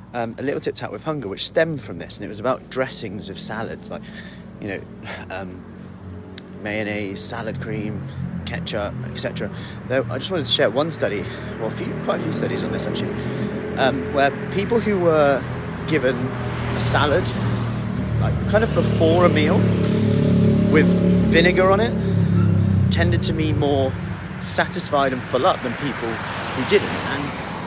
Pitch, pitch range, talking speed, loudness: 125 Hz, 100-165 Hz, 165 wpm, -21 LUFS